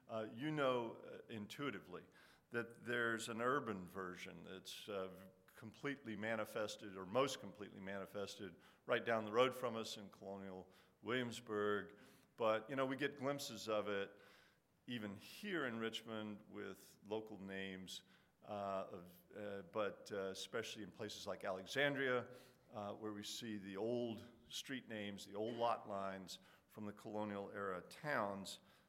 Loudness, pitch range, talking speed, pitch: -45 LUFS, 100-115 Hz, 145 wpm, 105 Hz